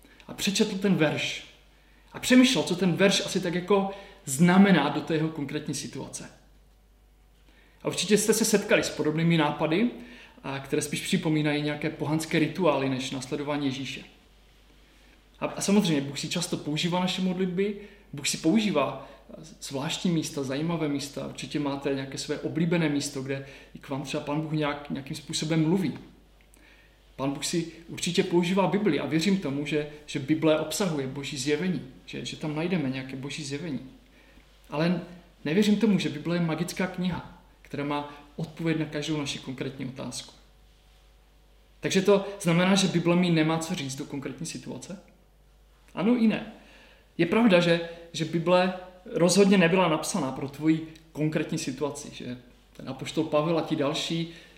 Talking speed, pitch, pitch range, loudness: 155 wpm, 155 Hz, 145-180 Hz, -27 LUFS